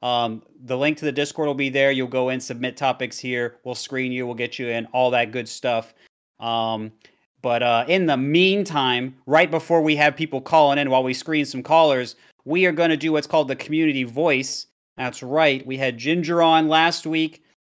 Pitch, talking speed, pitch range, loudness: 135 Hz, 210 wpm, 125-160 Hz, -21 LUFS